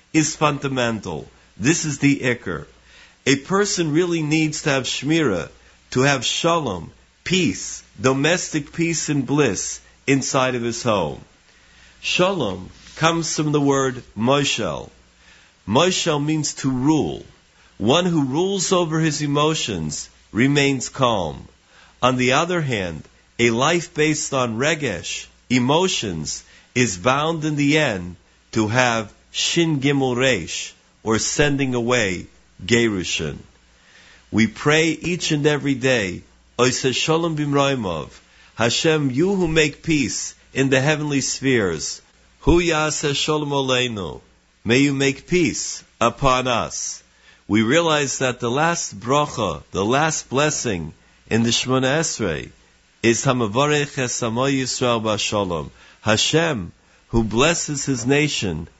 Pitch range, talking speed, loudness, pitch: 115-155 Hz, 110 wpm, -20 LUFS, 135 Hz